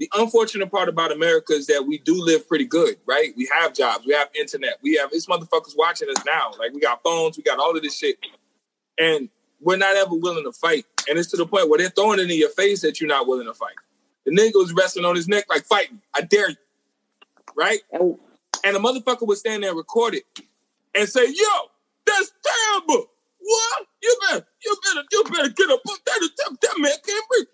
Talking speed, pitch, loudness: 220 wpm, 265 Hz, -20 LUFS